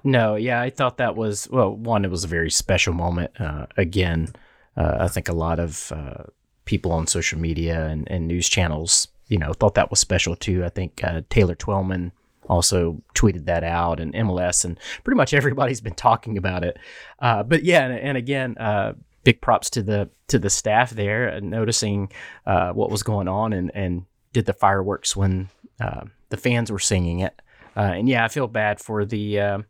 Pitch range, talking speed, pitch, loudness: 85-115 Hz, 200 wpm, 100 Hz, -22 LUFS